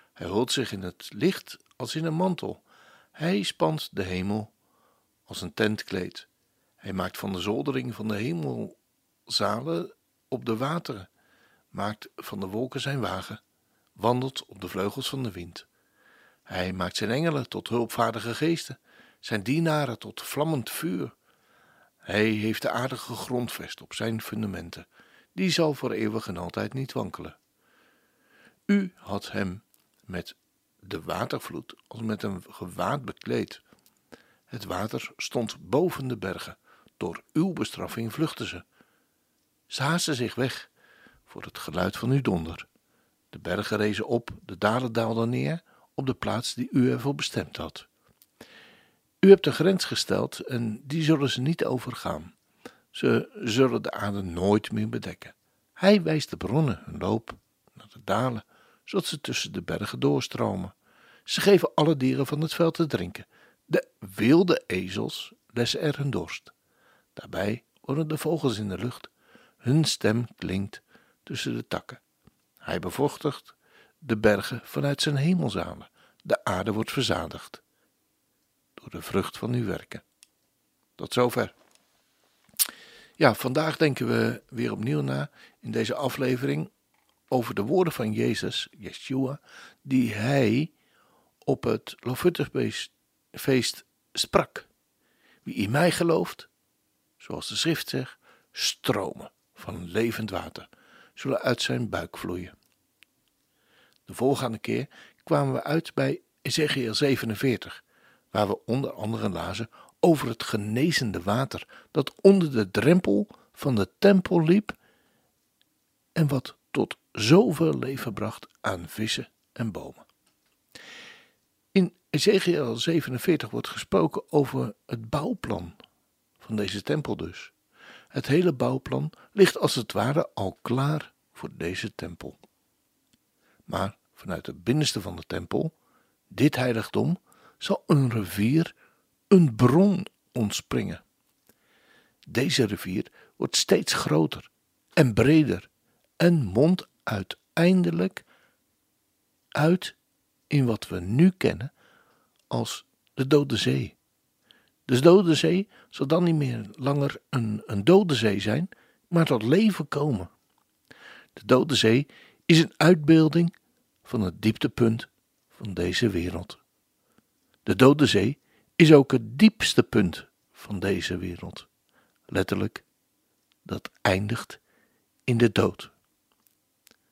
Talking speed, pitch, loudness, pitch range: 130 wpm, 125 Hz, -26 LUFS, 105-150 Hz